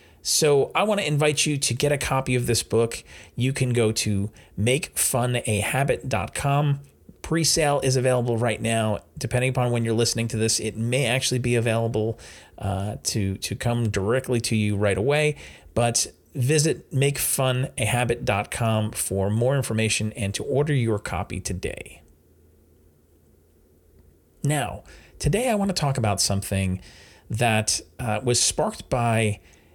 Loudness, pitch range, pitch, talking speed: -23 LUFS, 100-130 Hz, 115 Hz, 140 wpm